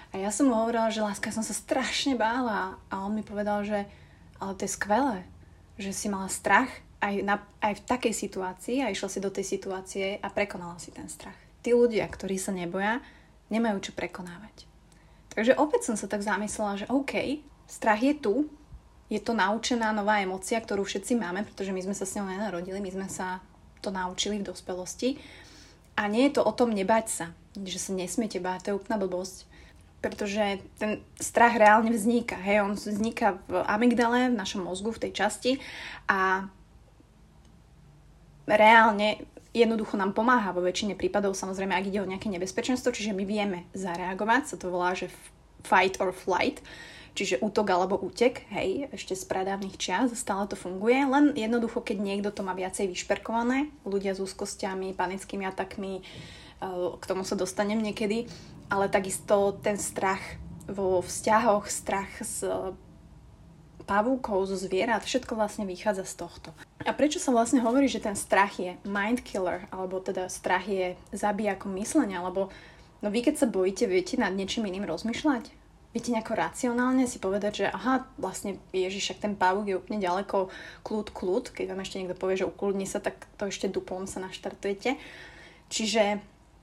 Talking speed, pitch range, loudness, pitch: 170 wpm, 190-225 Hz, -28 LUFS, 205 Hz